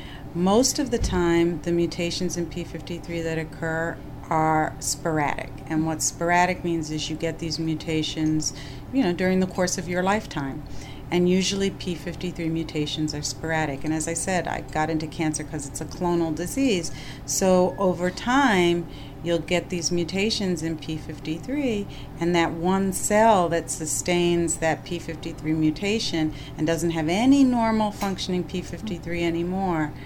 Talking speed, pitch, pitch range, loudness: 150 wpm, 165 Hz, 155-180 Hz, -24 LUFS